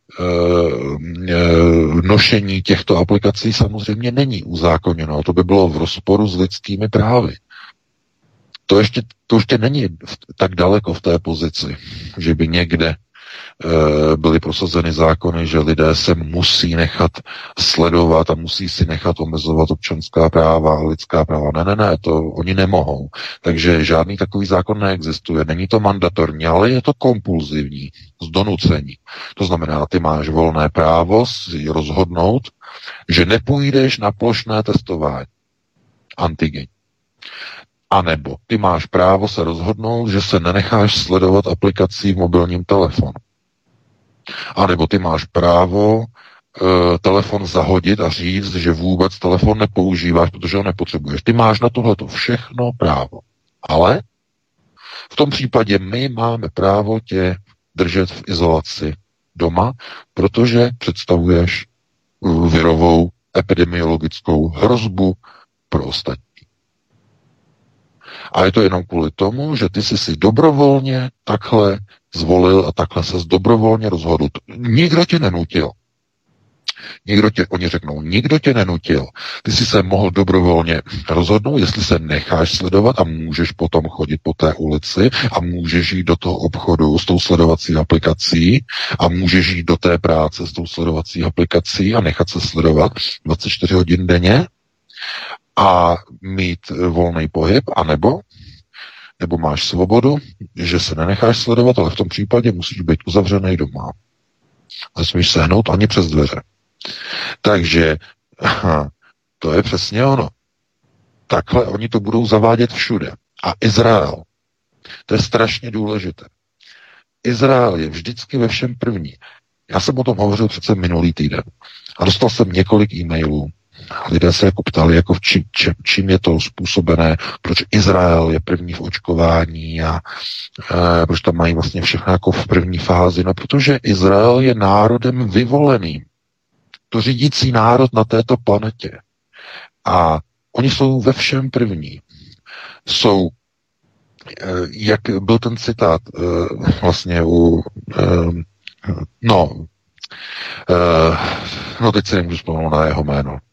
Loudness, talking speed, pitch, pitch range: -15 LUFS, 130 wpm, 90 Hz, 85-105 Hz